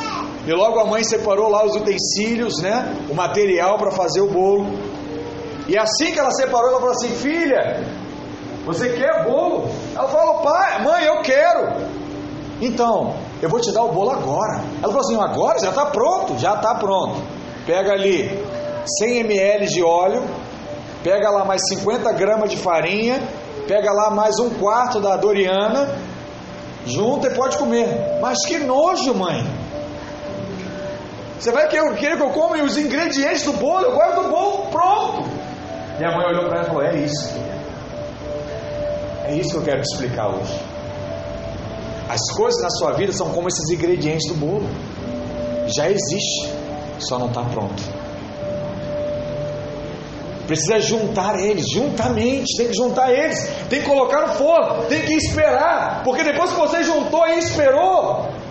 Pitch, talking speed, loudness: 210 Hz, 155 wpm, -19 LUFS